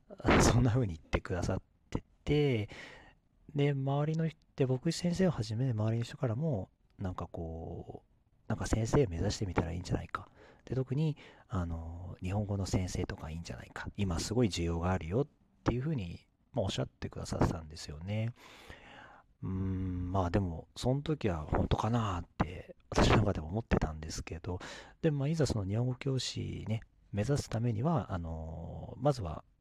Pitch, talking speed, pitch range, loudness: 105 Hz, 365 characters per minute, 90-125 Hz, -34 LUFS